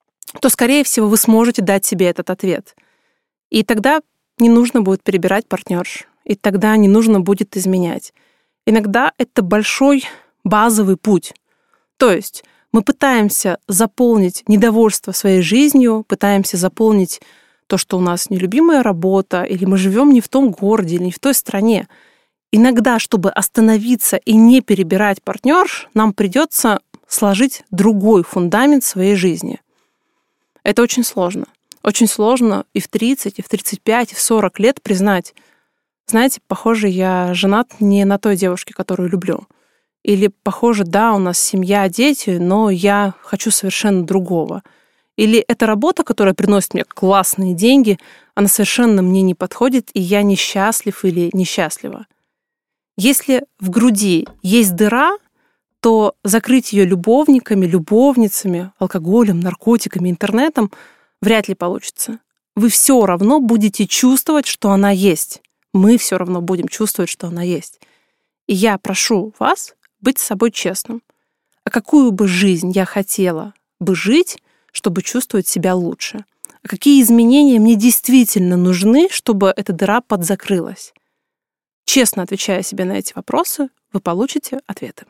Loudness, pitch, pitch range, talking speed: -14 LUFS, 215 Hz, 190-245 Hz, 140 wpm